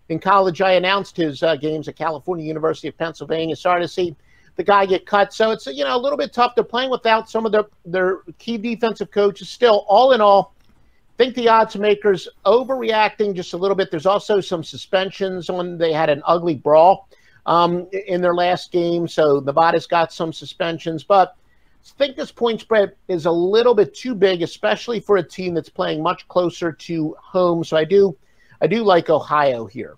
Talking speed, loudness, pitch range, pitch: 200 wpm, -18 LUFS, 165-210 Hz, 185 Hz